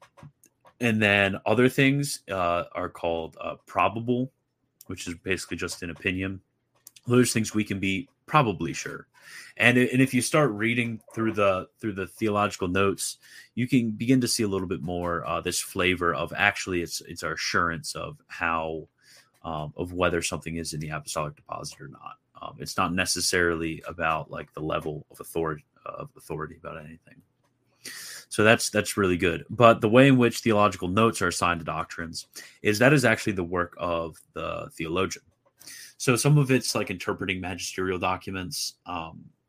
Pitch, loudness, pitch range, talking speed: 95 Hz, -25 LUFS, 90-115 Hz, 175 wpm